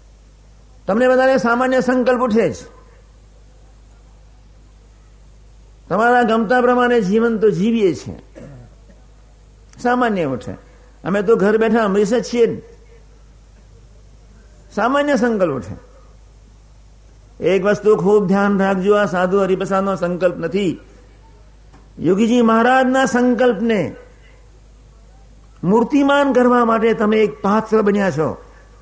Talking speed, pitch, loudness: 95 wpm, 195 Hz, -16 LUFS